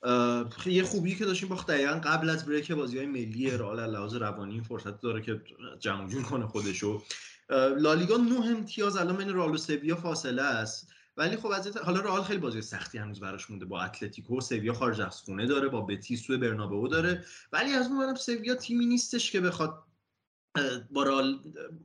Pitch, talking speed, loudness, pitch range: 135 Hz, 190 wpm, -31 LUFS, 115-185 Hz